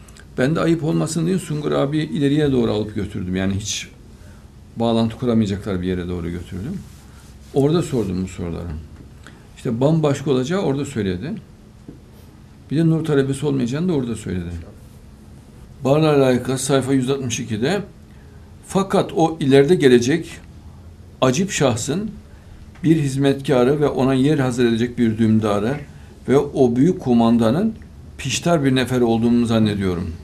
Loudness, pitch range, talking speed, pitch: -19 LUFS, 95-140 Hz, 125 wpm, 120 Hz